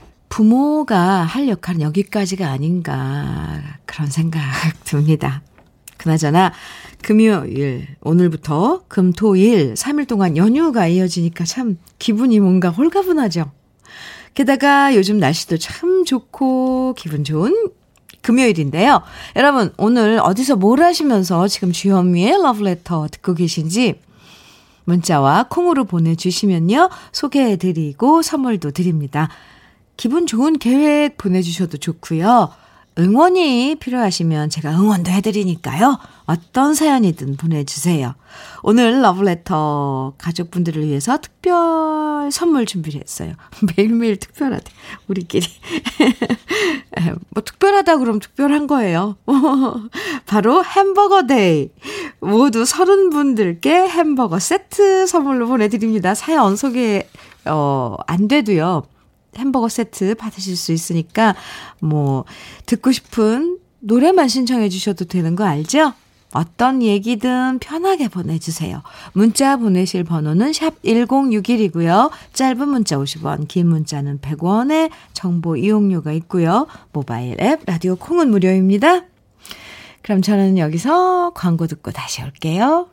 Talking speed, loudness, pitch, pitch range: 265 characters per minute, -16 LUFS, 205 Hz, 165-270 Hz